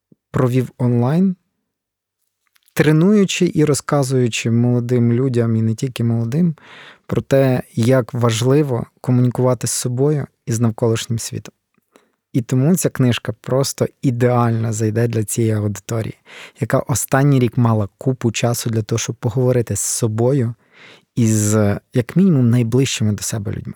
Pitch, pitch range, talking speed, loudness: 125 Hz, 115-135 Hz, 130 wpm, -17 LUFS